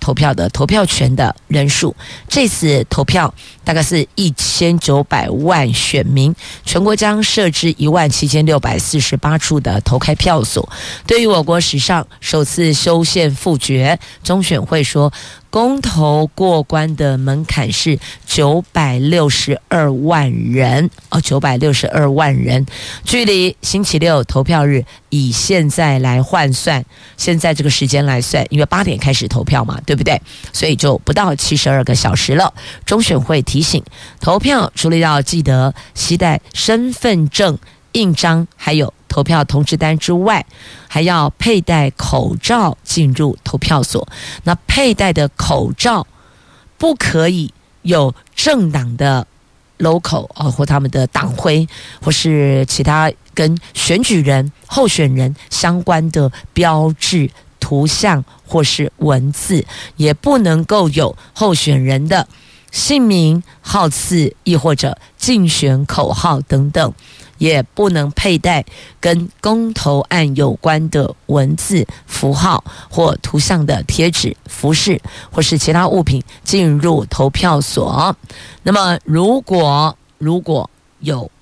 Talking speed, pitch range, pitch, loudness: 205 characters per minute, 140-170 Hz, 155 Hz, -14 LUFS